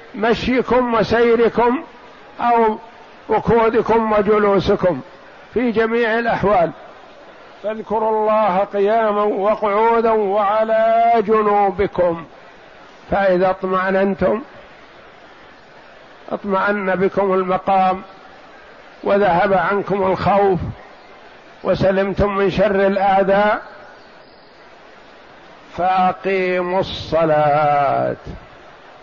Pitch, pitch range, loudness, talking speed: 200 Hz, 190-220 Hz, -17 LUFS, 60 wpm